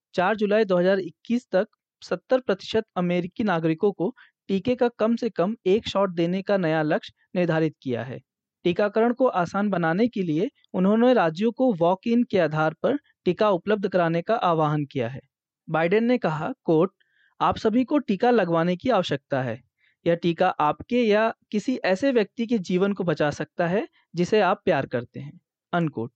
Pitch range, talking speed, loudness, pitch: 165-220 Hz, 170 wpm, -24 LUFS, 185 Hz